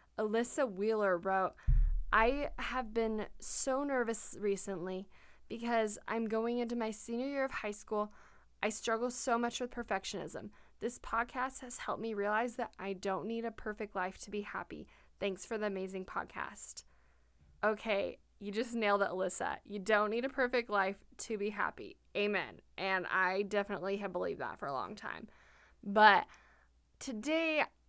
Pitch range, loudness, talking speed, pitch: 195-235 Hz, -35 LUFS, 160 wpm, 215 Hz